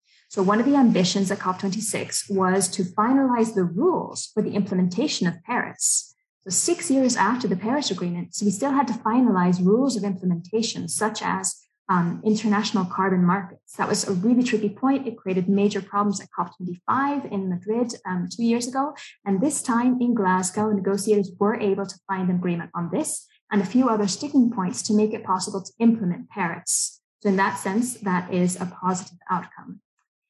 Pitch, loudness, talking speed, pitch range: 205 Hz, -23 LUFS, 185 wpm, 185-235 Hz